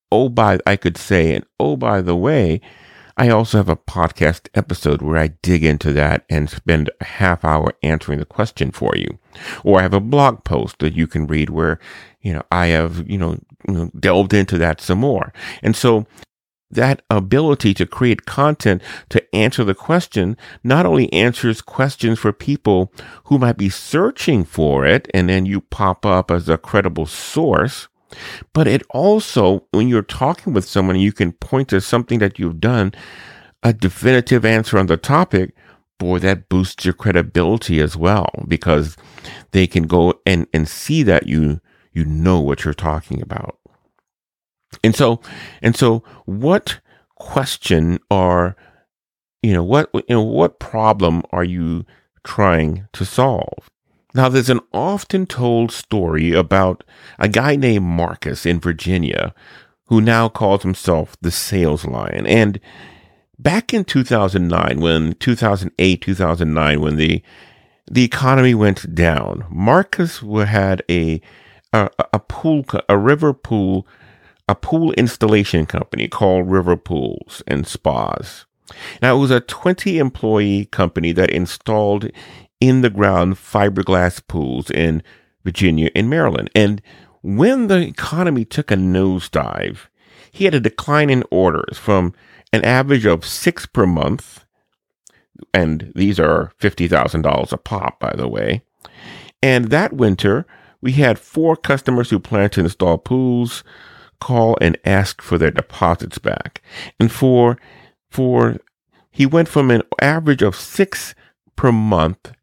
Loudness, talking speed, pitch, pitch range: -17 LUFS, 150 wpm, 100 Hz, 85-120 Hz